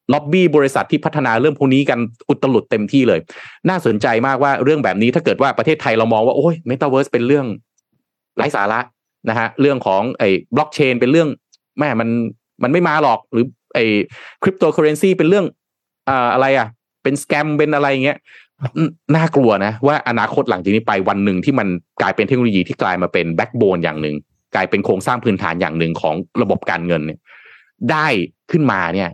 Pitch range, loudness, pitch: 105-145 Hz, -16 LUFS, 130 Hz